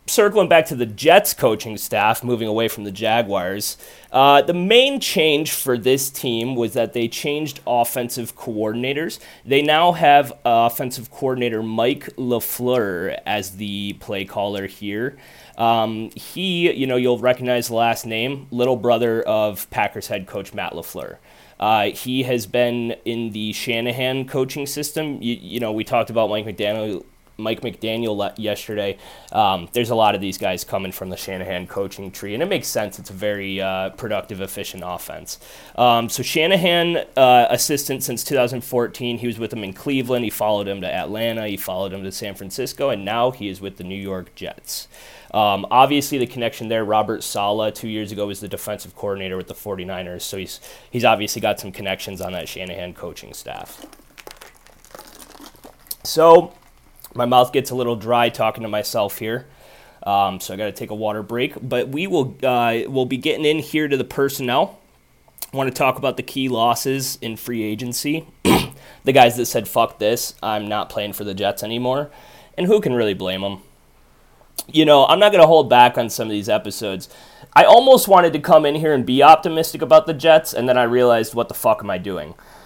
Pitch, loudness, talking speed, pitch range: 120 Hz, -19 LUFS, 185 wpm, 105-130 Hz